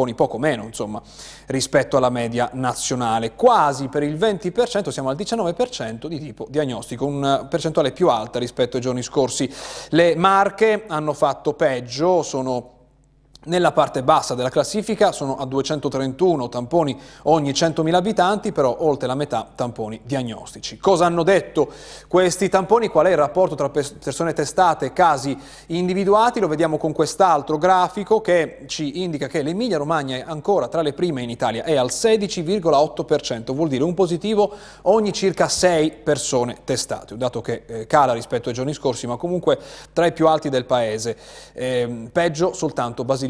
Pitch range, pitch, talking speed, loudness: 130-175 Hz, 150 Hz, 155 wpm, -20 LUFS